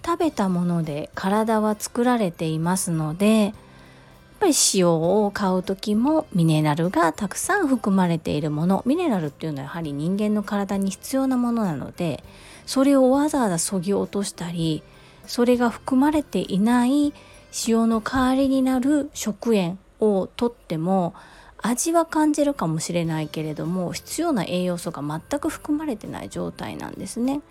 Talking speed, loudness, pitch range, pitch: 320 characters per minute, -23 LUFS, 175-260 Hz, 210 Hz